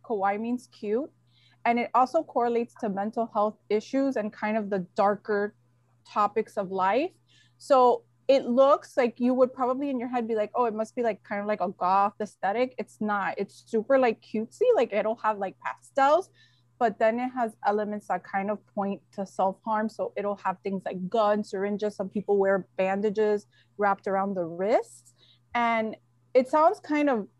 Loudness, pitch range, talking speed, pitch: -27 LUFS, 195-240 Hz, 185 wpm, 210 Hz